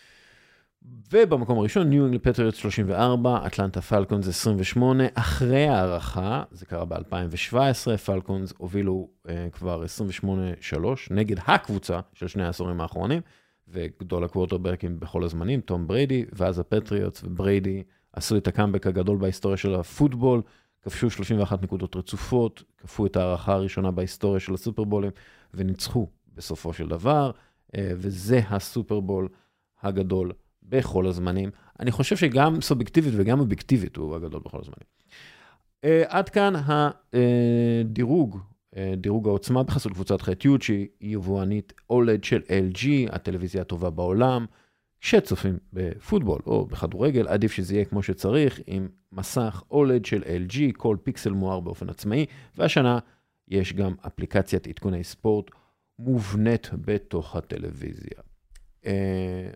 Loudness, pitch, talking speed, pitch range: -25 LUFS, 100 Hz, 120 wpm, 95-120 Hz